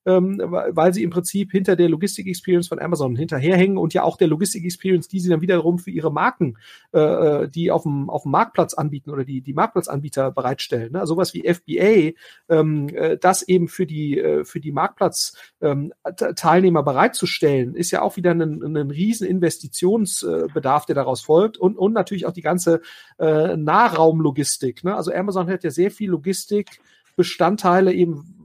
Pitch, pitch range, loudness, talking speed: 175 Hz, 155-185 Hz, -20 LUFS, 150 wpm